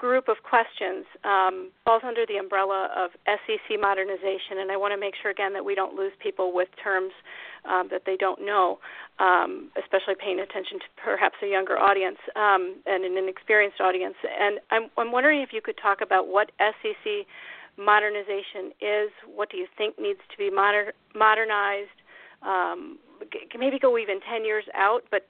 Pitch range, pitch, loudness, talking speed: 195-230 Hz, 205 Hz, -25 LUFS, 180 wpm